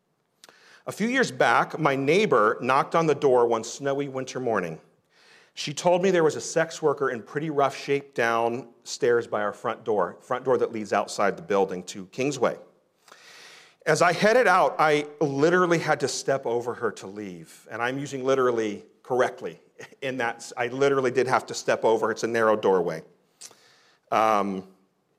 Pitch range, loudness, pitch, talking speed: 115-165 Hz, -24 LUFS, 140 Hz, 175 wpm